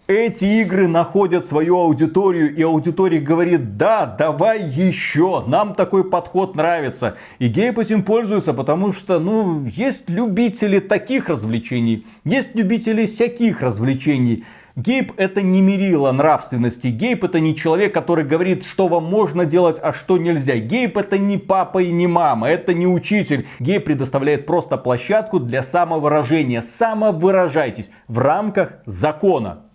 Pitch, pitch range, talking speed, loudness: 175 Hz, 150-200 Hz, 135 wpm, -17 LUFS